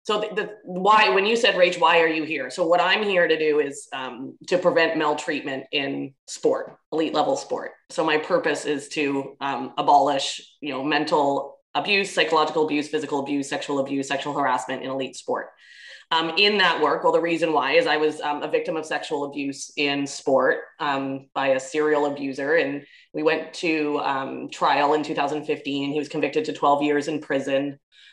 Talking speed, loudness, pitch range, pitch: 190 wpm, -23 LUFS, 140-165 Hz, 150 Hz